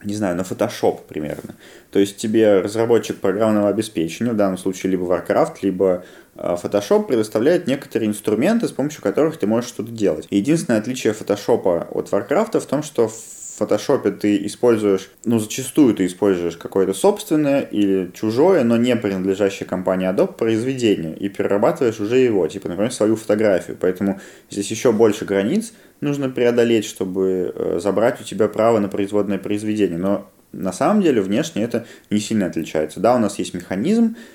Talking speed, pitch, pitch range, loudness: 160 wpm, 105 Hz, 95-115 Hz, -19 LUFS